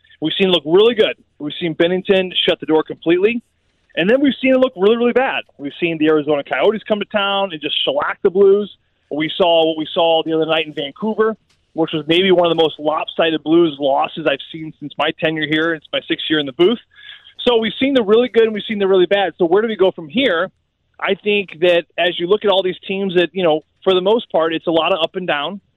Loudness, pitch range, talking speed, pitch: -16 LUFS, 160-210 Hz, 260 wpm, 180 Hz